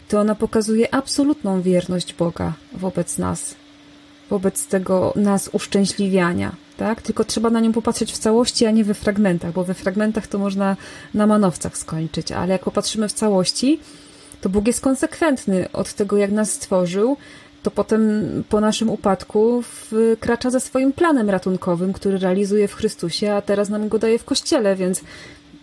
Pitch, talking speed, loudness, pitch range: 210 Hz, 160 wpm, -20 LUFS, 190-230 Hz